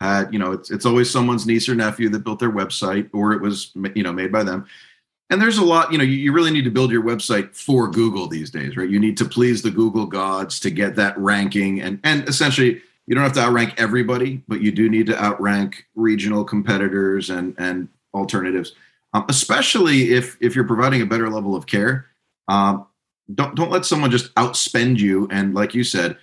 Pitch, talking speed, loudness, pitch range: 110 Hz, 215 wpm, -19 LUFS, 100-125 Hz